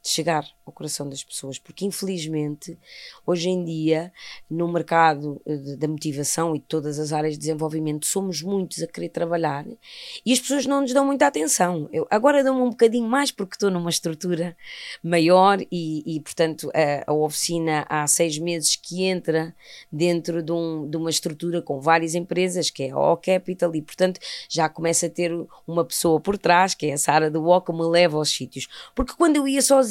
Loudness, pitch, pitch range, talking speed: -22 LUFS, 170 Hz, 155-185 Hz, 200 wpm